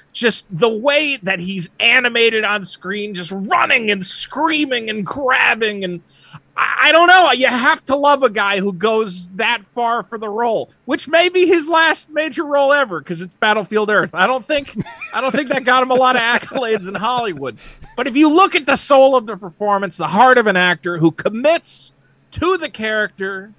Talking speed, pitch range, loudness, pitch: 200 wpm, 200-280 Hz, -15 LUFS, 235 Hz